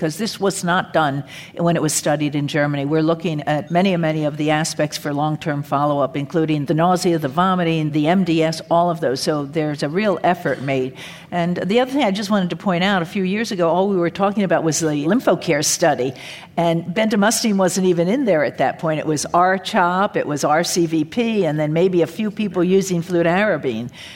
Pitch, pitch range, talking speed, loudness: 170 Hz, 155-190 Hz, 215 wpm, -19 LUFS